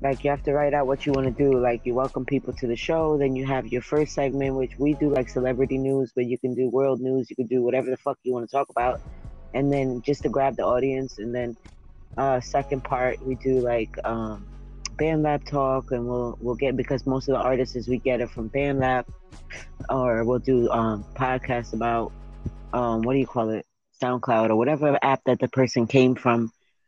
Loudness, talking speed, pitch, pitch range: -25 LUFS, 230 wpm, 130 Hz, 120-135 Hz